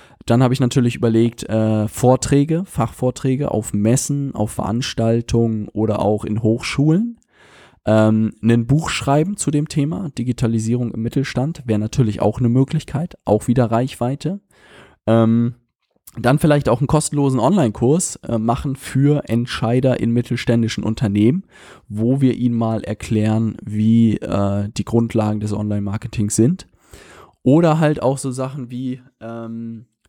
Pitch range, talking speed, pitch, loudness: 110-135 Hz, 135 wpm, 120 Hz, -18 LUFS